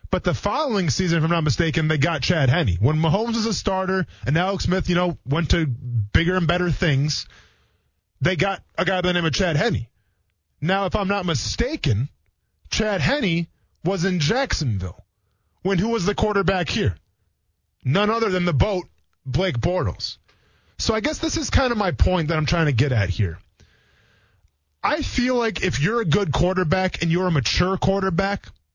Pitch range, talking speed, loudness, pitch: 115-190 Hz, 190 wpm, -22 LUFS, 165 Hz